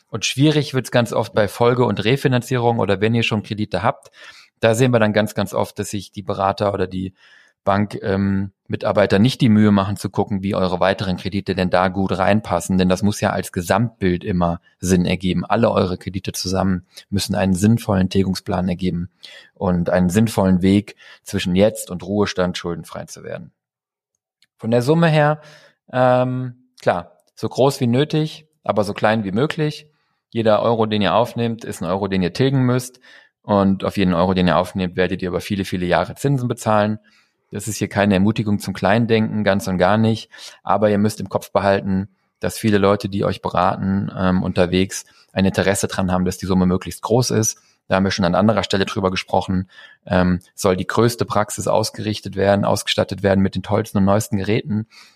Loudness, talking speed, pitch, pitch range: -19 LUFS, 190 wpm, 100 Hz, 95-110 Hz